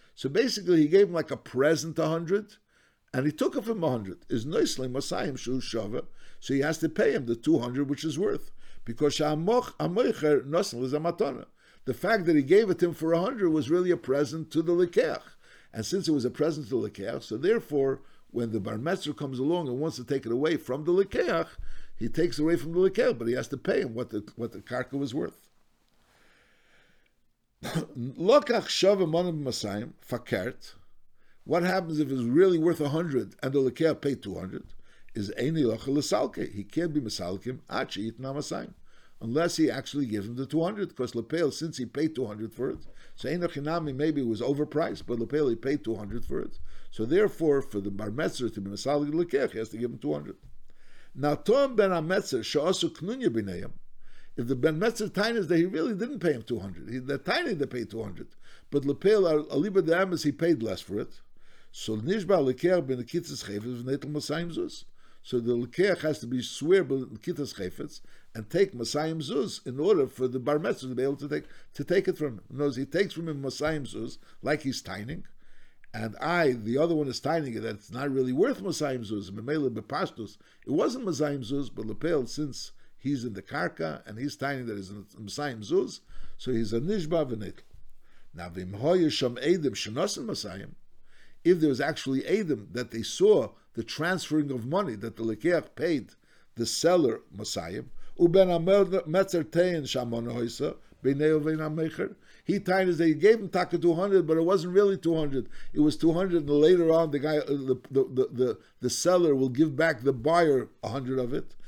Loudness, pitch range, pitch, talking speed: -28 LUFS, 125-170 Hz, 145 Hz, 185 wpm